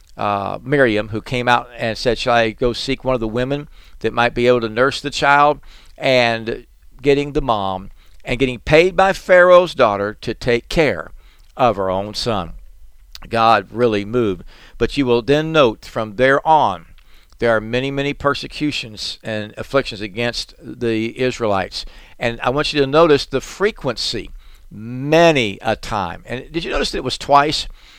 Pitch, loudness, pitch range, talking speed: 120 Hz, -17 LUFS, 105-140 Hz, 170 wpm